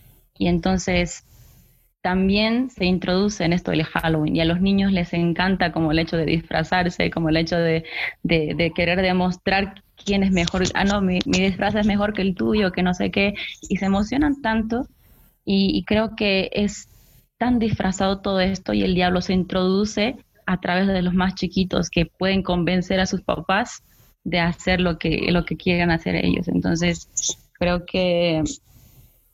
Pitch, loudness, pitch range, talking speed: 185 Hz, -21 LUFS, 175-195 Hz, 180 wpm